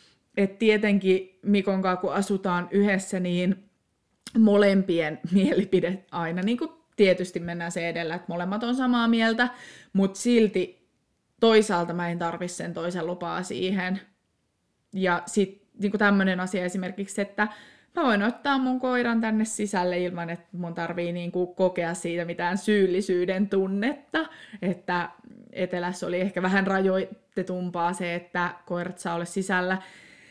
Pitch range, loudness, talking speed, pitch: 175-210 Hz, -26 LUFS, 135 wpm, 190 Hz